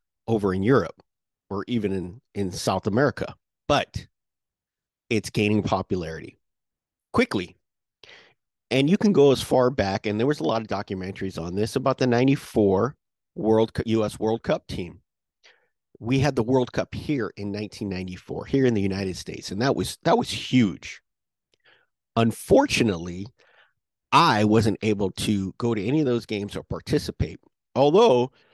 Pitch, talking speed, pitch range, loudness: 110 Hz, 150 wpm, 100-125 Hz, -24 LUFS